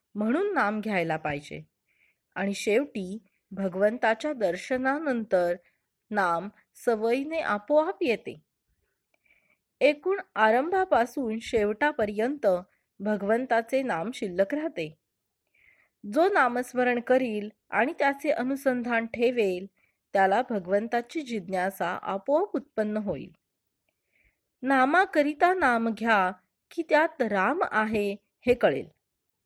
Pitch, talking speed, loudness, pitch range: 230 Hz, 85 wpm, -27 LUFS, 200-275 Hz